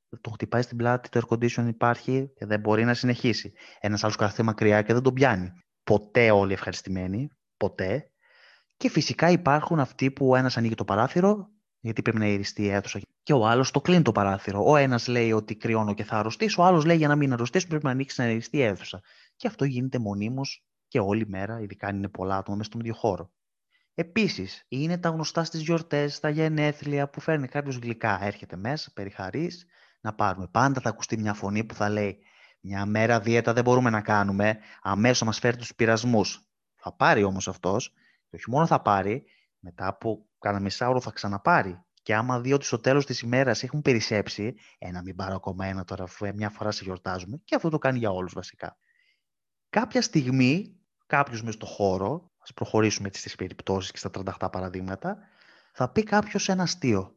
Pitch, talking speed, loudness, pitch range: 115 Hz, 195 wpm, -26 LUFS, 100-140 Hz